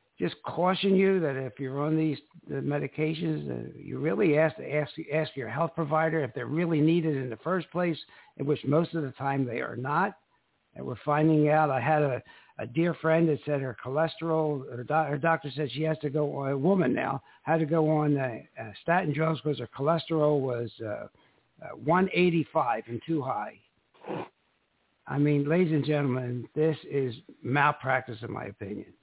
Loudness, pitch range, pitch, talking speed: -28 LUFS, 130-160 Hz, 150 Hz, 190 wpm